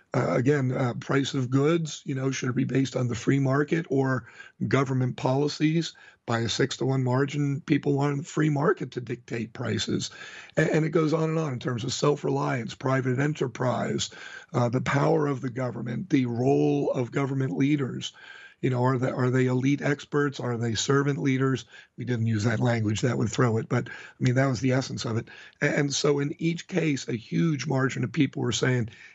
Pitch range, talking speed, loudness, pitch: 125-145 Hz, 205 wpm, -26 LUFS, 135 Hz